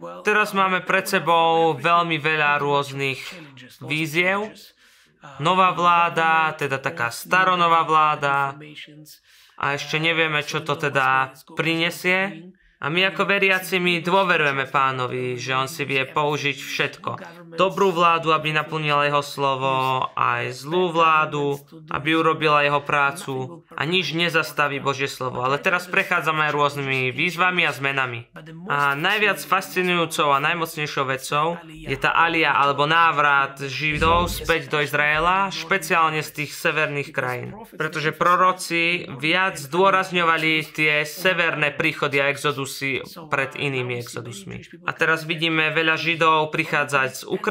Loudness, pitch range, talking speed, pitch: -20 LUFS, 140-170 Hz, 125 wpm, 155 Hz